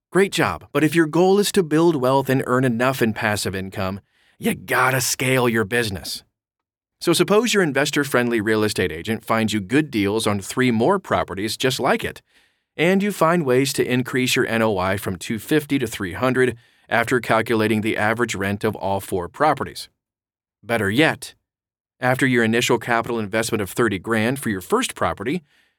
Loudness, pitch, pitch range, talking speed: -20 LUFS, 120 Hz, 110-135 Hz, 175 wpm